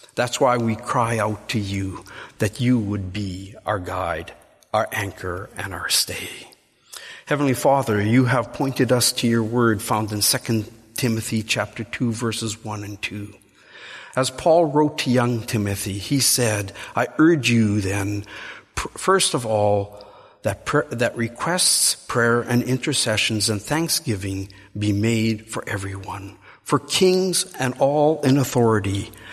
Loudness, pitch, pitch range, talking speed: -21 LUFS, 110 Hz, 105-125 Hz, 145 wpm